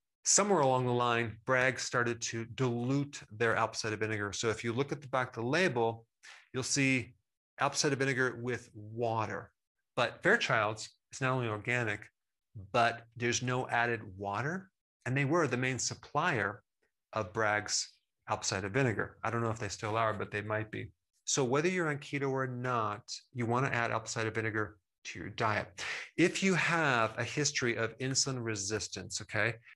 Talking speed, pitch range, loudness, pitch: 175 wpm, 110-130 Hz, -33 LUFS, 115 Hz